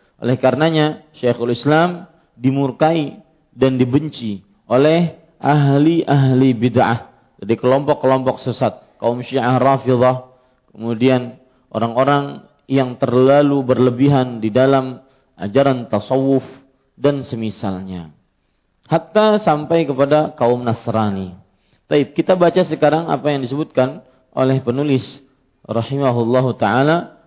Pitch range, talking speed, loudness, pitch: 125-145 Hz, 95 wpm, -16 LUFS, 130 Hz